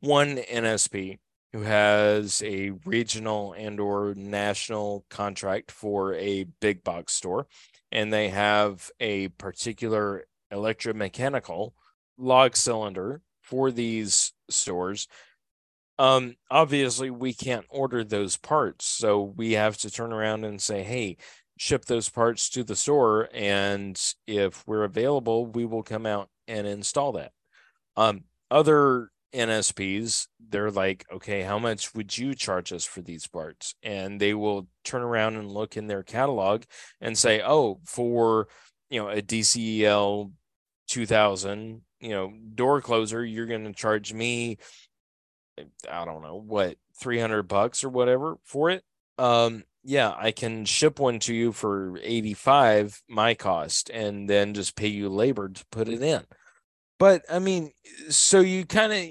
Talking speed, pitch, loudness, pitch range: 145 wpm, 110 Hz, -25 LUFS, 100-120 Hz